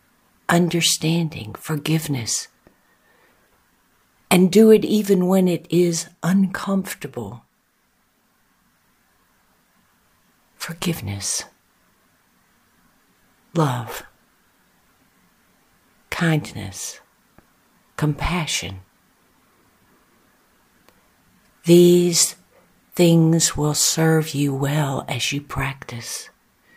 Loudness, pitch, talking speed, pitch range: -19 LUFS, 160 Hz, 50 wpm, 140-175 Hz